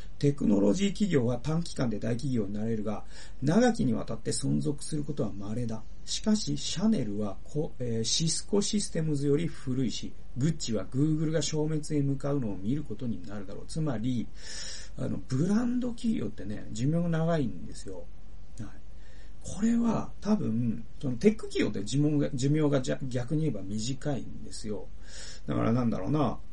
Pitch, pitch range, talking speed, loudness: 135 Hz, 105-155 Hz, 345 characters per minute, -30 LUFS